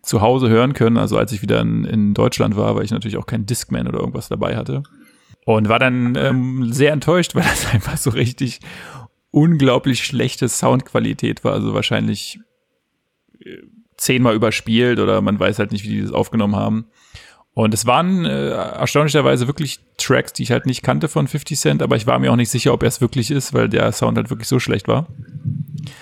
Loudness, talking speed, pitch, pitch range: -17 LUFS, 195 wpm, 125 Hz, 110-140 Hz